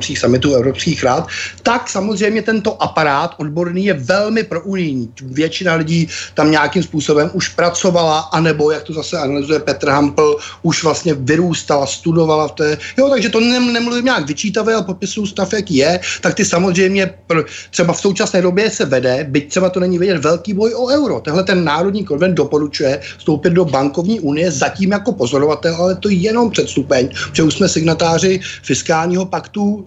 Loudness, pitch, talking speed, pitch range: -15 LUFS, 170 Hz, 175 wpm, 150-195 Hz